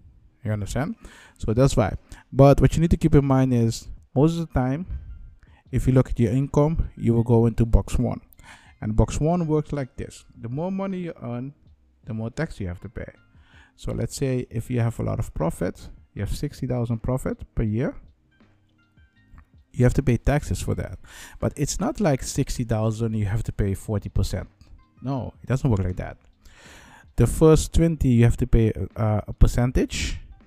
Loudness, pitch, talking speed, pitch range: -24 LUFS, 115 Hz, 190 wpm, 100-130 Hz